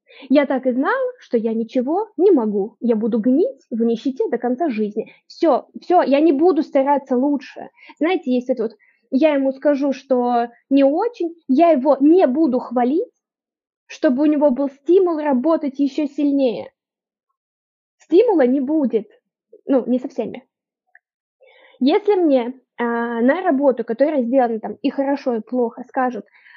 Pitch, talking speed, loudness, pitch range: 275 Hz, 150 wpm, -18 LUFS, 245-320 Hz